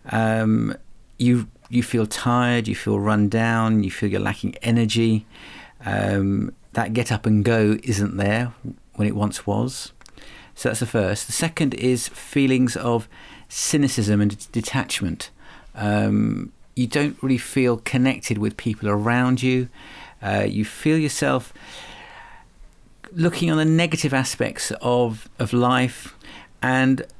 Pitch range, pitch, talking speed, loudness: 105-130 Hz, 120 Hz, 135 wpm, -22 LUFS